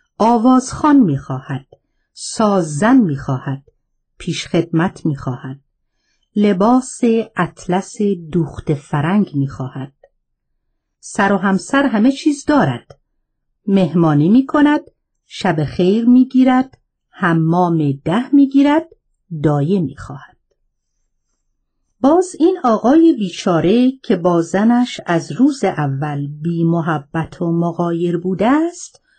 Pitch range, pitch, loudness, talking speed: 155-250 Hz, 185 Hz, -15 LUFS, 105 wpm